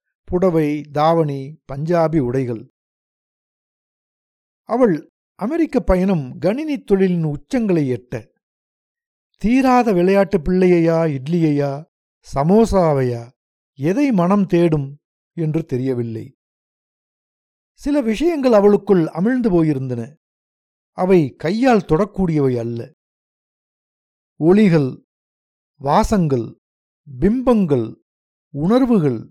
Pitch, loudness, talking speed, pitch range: 165 Hz, -17 LUFS, 70 wpm, 135-200 Hz